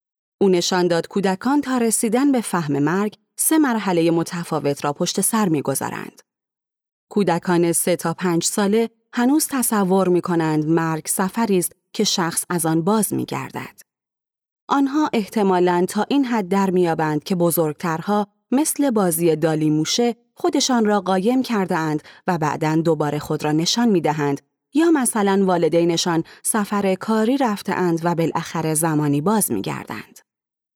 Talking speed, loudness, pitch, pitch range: 145 wpm, -20 LUFS, 185 Hz, 165-220 Hz